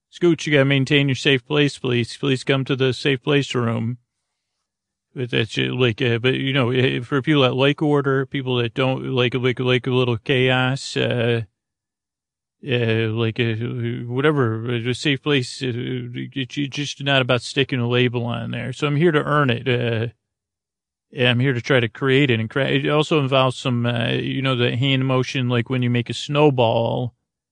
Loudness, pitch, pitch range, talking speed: -20 LUFS, 130 Hz, 120-140 Hz, 195 wpm